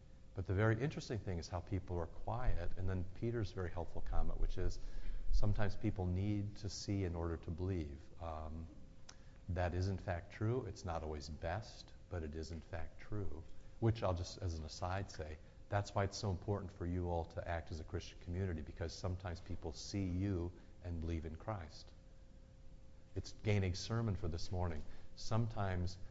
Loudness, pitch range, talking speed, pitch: -43 LUFS, 85-100 Hz, 185 wpm, 90 Hz